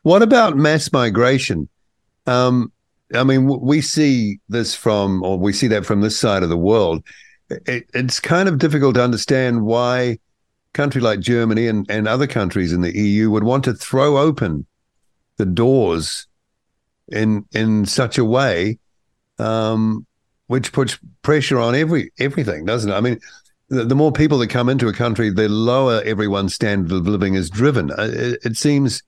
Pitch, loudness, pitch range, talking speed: 120 Hz, -17 LUFS, 105-130 Hz, 170 wpm